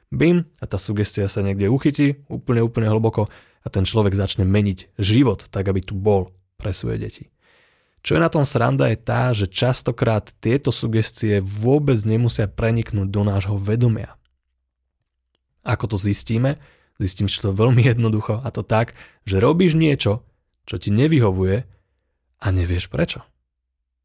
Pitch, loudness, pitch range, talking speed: 110 Hz, -20 LUFS, 95-125 Hz, 150 wpm